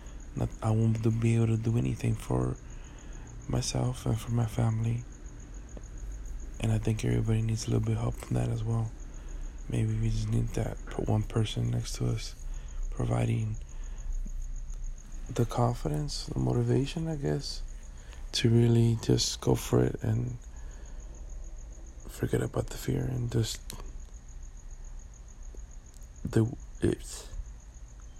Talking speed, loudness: 125 wpm, -30 LUFS